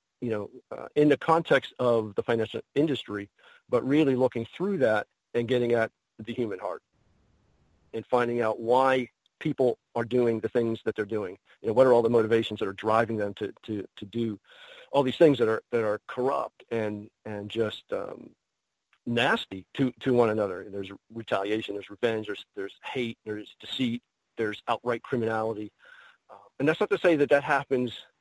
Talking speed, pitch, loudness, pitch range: 185 wpm, 115 Hz, -27 LUFS, 105-130 Hz